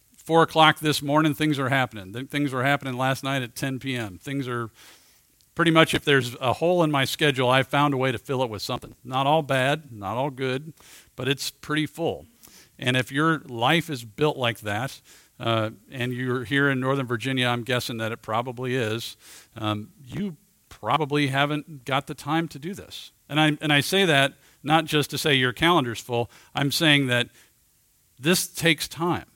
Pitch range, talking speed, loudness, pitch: 125-150 Hz, 195 wpm, -24 LUFS, 135 Hz